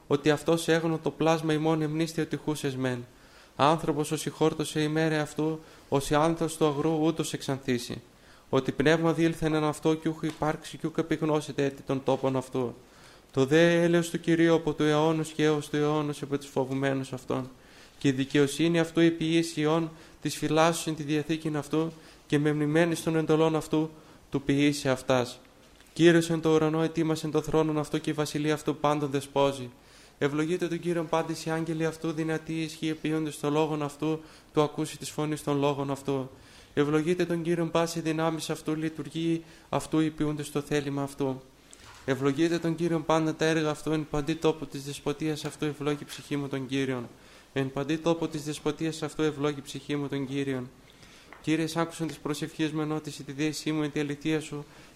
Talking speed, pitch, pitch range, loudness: 180 wpm, 155 Hz, 145-160 Hz, -28 LUFS